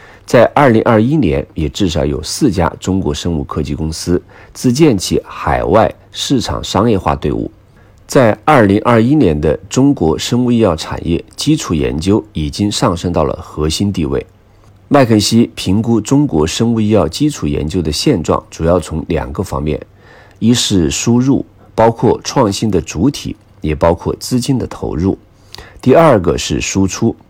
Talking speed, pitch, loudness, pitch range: 245 characters per minute, 105 Hz, -13 LUFS, 85-120 Hz